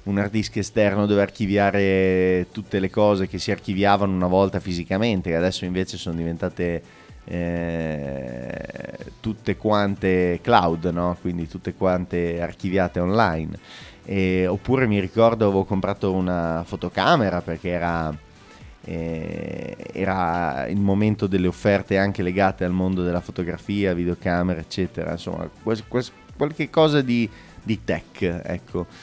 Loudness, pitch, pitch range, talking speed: -23 LUFS, 95 Hz, 90-100 Hz, 125 wpm